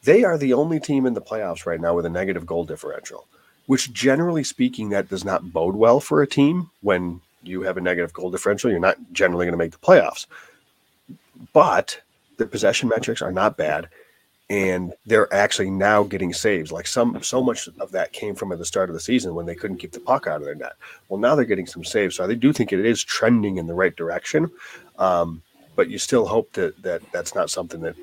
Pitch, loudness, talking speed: 100 Hz, -21 LUFS, 225 wpm